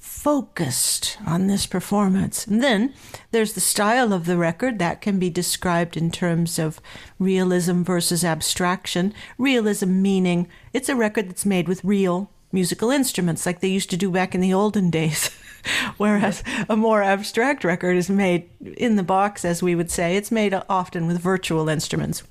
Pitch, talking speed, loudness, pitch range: 190 Hz, 170 wpm, -21 LUFS, 175-210 Hz